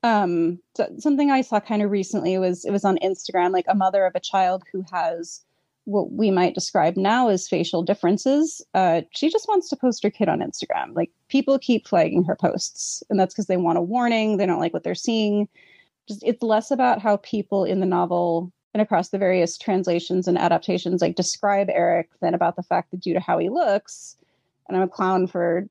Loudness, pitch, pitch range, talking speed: -22 LUFS, 190 Hz, 180-215 Hz, 215 wpm